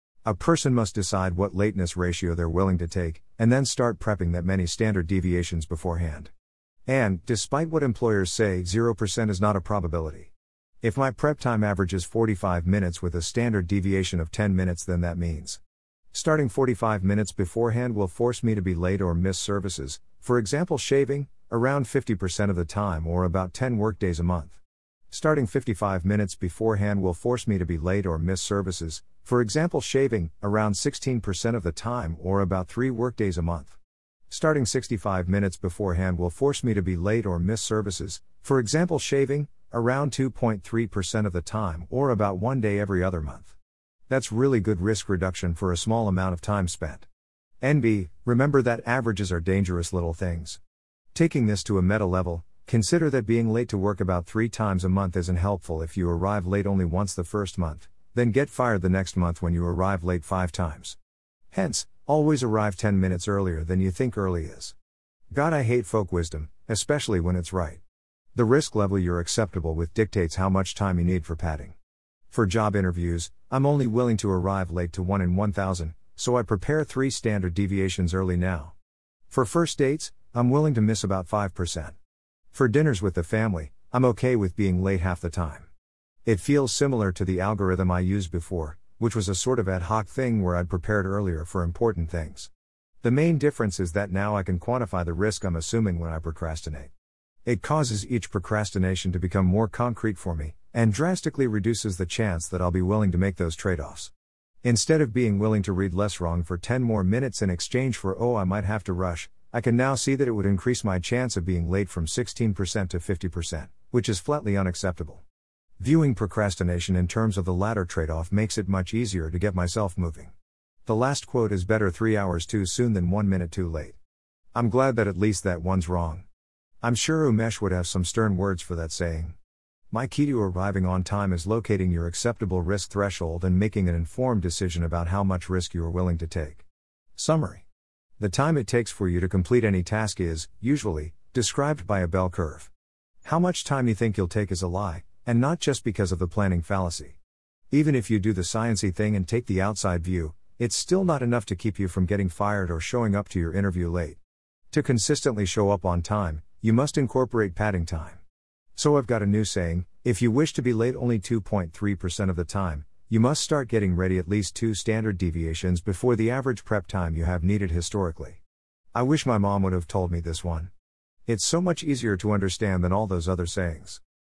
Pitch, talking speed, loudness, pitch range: 95 Hz, 200 wpm, -26 LUFS, 90-115 Hz